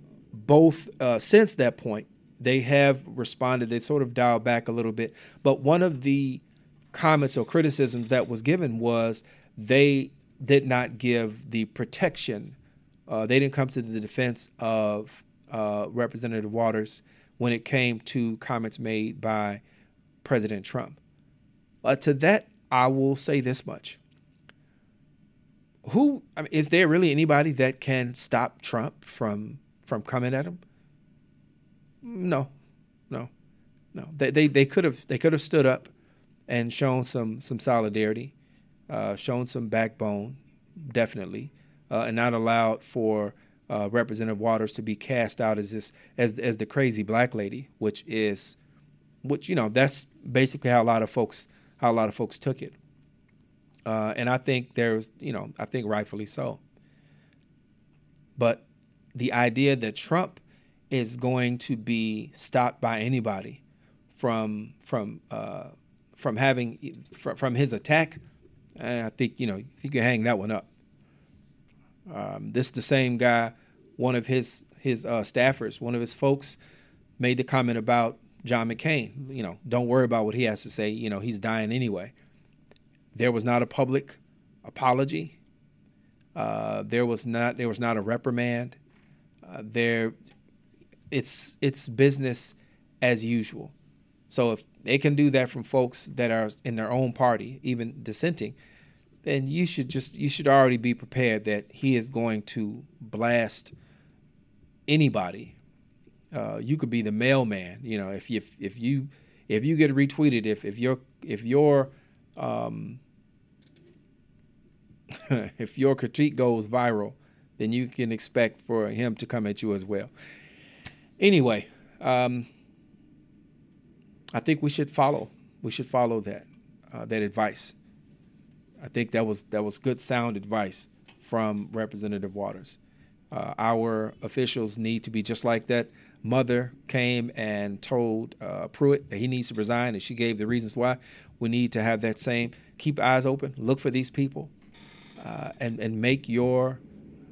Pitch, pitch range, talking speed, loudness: 120 Hz, 110-135 Hz, 155 wpm, -27 LUFS